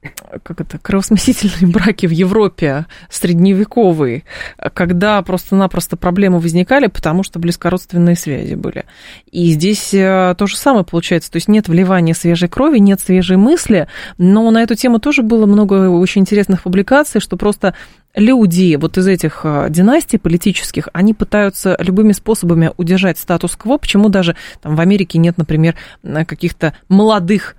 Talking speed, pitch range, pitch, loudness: 140 wpm, 170-210 Hz, 185 Hz, -12 LUFS